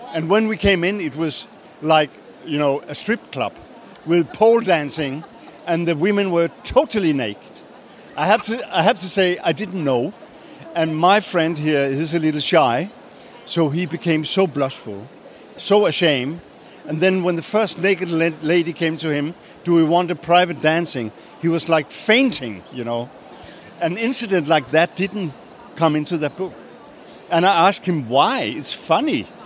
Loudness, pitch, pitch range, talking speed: -19 LUFS, 170 Hz, 155-190 Hz, 175 wpm